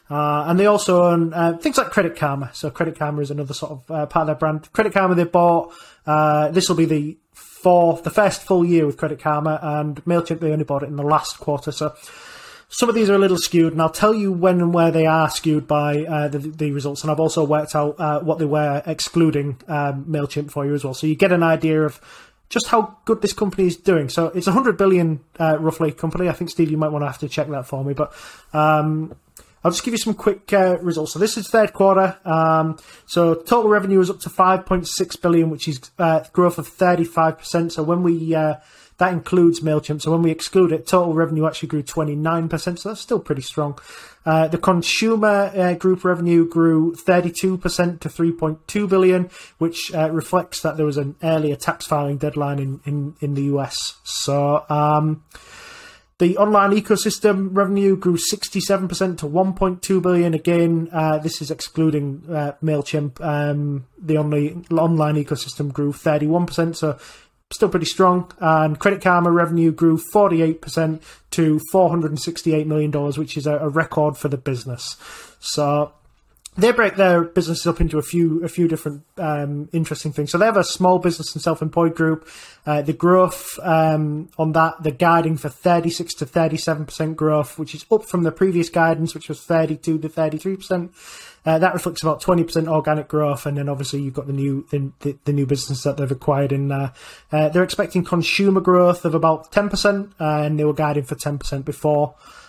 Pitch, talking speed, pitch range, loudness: 160 Hz, 200 wpm, 150-180 Hz, -19 LUFS